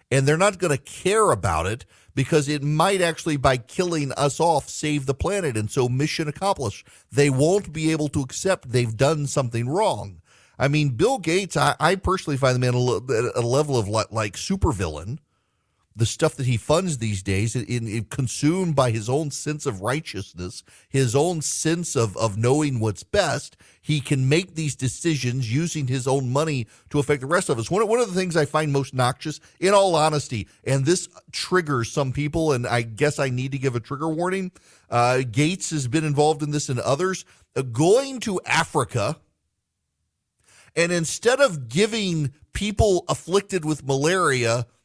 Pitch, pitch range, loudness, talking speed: 140 Hz, 120-160 Hz, -23 LUFS, 180 wpm